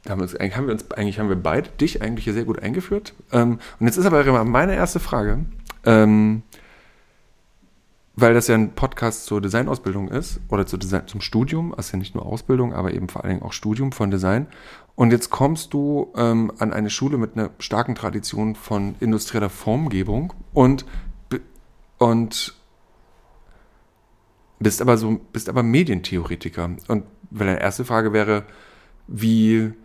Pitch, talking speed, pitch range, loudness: 110 Hz, 145 wpm, 100-120 Hz, -21 LUFS